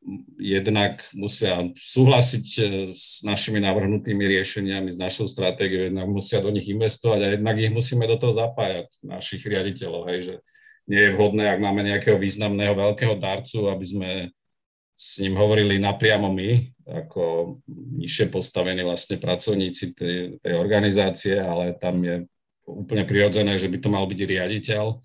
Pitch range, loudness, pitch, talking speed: 95-110 Hz, -23 LUFS, 100 Hz, 145 wpm